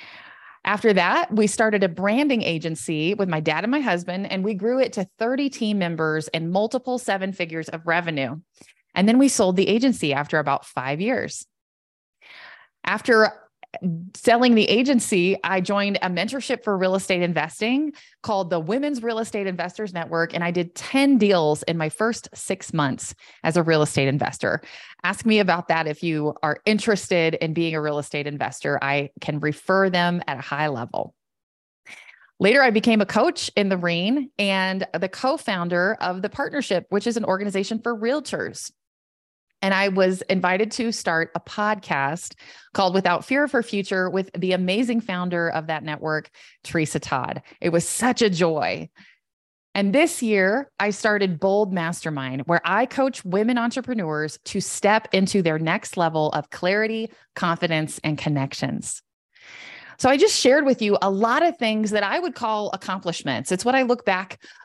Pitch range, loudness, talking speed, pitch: 165-225 Hz, -22 LUFS, 170 wpm, 190 Hz